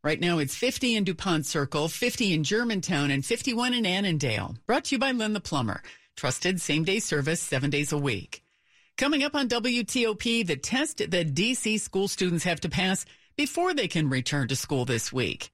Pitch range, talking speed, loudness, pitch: 150-235 Hz, 195 wpm, -27 LUFS, 180 Hz